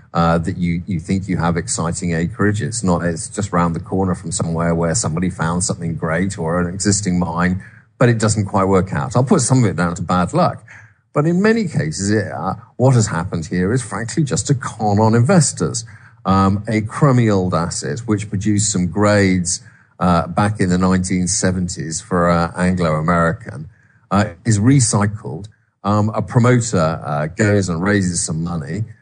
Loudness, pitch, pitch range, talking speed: -17 LUFS, 100 Hz, 90-115 Hz, 185 wpm